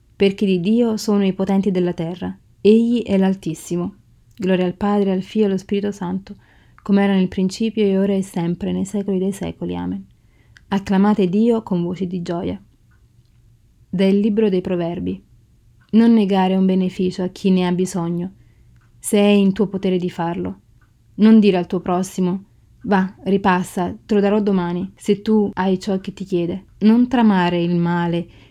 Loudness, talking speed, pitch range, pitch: -19 LUFS, 170 wpm, 175-200 Hz, 185 Hz